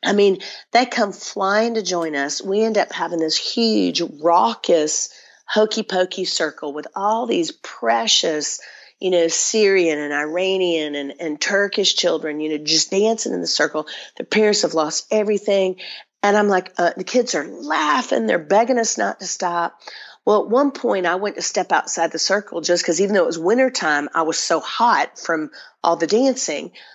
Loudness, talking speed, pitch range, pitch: -19 LUFS, 185 wpm, 160-210 Hz, 185 Hz